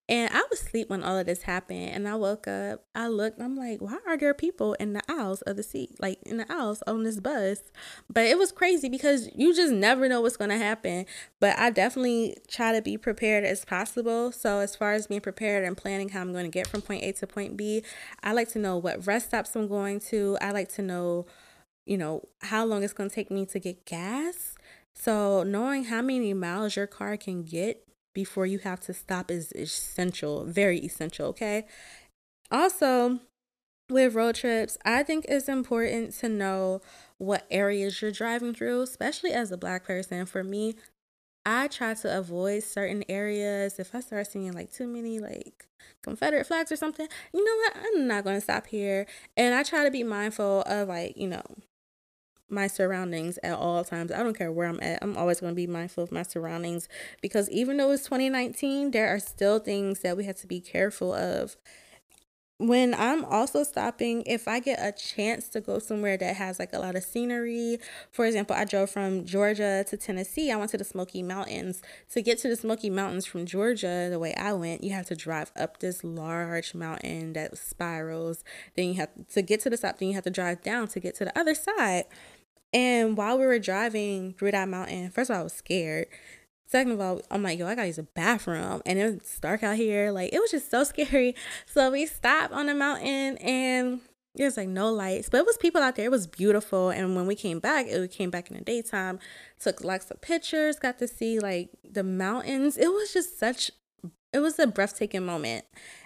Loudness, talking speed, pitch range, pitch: -28 LUFS, 210 wpm, 185-240 Hz, 205 Hz